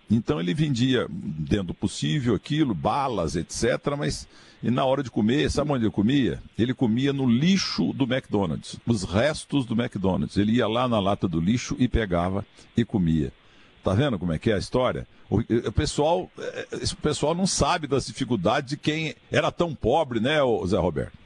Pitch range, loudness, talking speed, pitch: 115-150 Hz, -25 LUFS, 185 wpm, 130 Hz